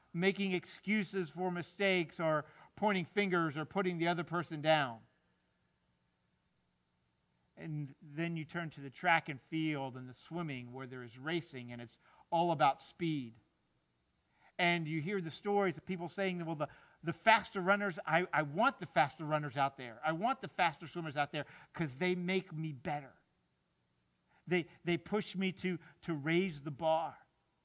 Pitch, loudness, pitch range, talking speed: 160 Hz, -36 LUFS, 135-180 Hz, 165 wpm